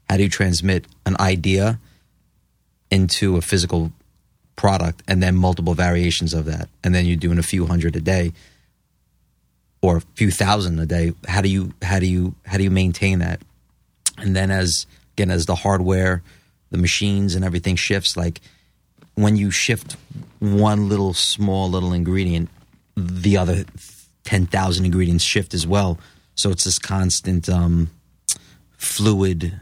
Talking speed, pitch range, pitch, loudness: 155 wpm, 85-95 Hz, 90 Hz, -20 LUFS